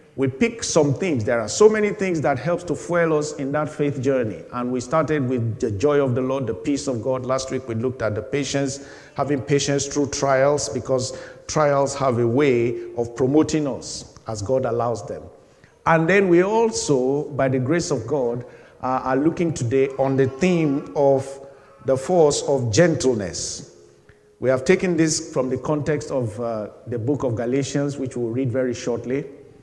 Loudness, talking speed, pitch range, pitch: -21 LUFS, 190 wpm, 130-150 Hz, 135 Hz